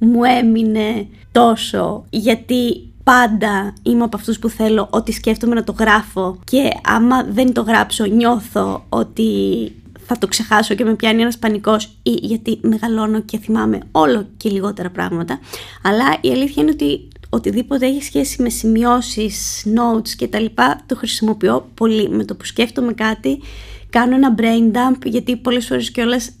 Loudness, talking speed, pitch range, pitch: -16 LUFS, 155 wpm, 200-235 Hz, 220 Hz